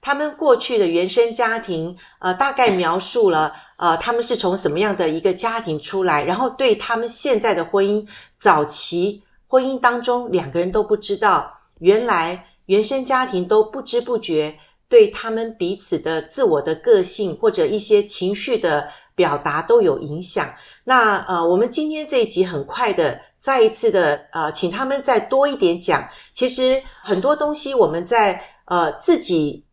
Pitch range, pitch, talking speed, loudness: 185-275 Hz, 230 Hz, 250 characters per minute, -19 LUFS